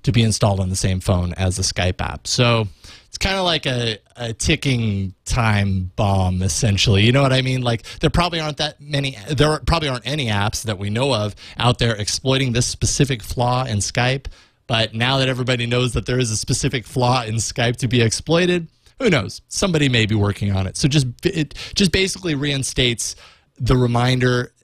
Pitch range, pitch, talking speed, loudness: 105-135 Hz, 120 Hz, 200 wpm, -19 LUFS